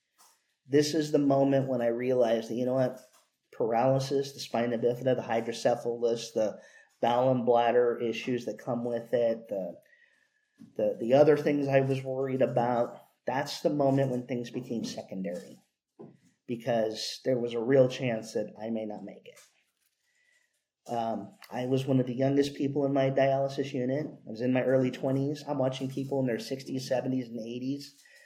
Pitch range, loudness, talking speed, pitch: 120-135 Hz, -29 LUFS, 170 wpm, 130 Hz